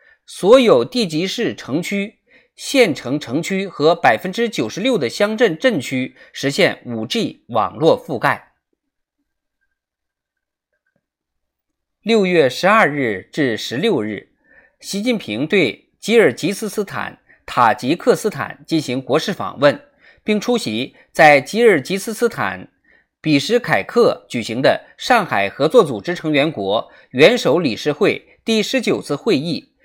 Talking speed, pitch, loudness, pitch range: 195 characters per minute, 210 Hz, -17 LUFS, 160-245 Hz